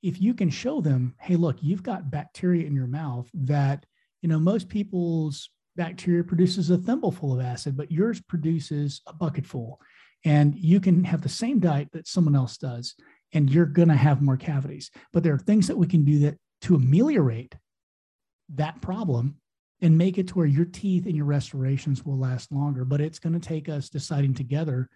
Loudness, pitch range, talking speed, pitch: -25 LUFS, 140-175 Hz, 195 wpm, 155 Hz